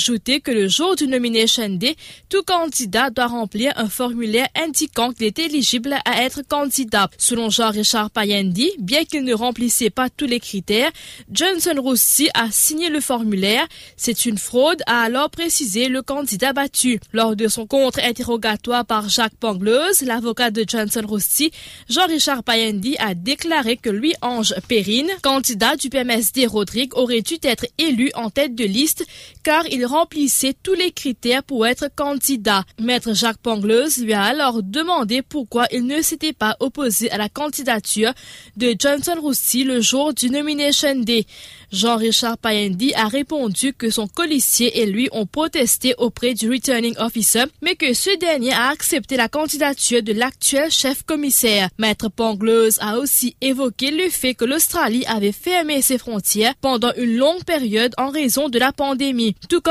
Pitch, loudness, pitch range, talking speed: 250 Hz, -18 LUFS, 225-285 Hz, 160 wpm